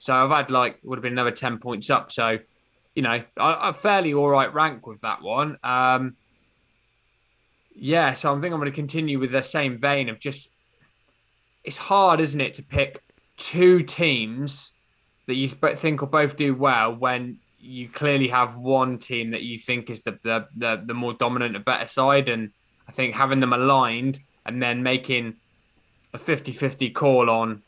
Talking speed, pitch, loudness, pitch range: 180 wpm, 130 Hz, -23 LUFS, 115-140 Hz